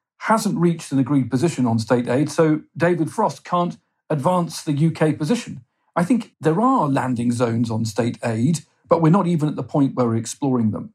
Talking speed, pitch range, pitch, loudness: 195 wpm, 125-170 Hz, 150 Hz, -20 LUFS